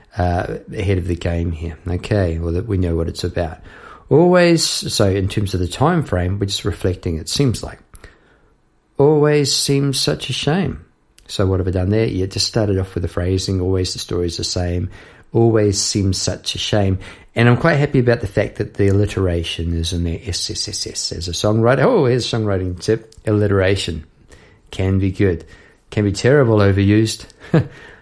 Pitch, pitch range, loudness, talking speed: 100 Hz, 90-115 Hz, -18 LUFS, 185 wpm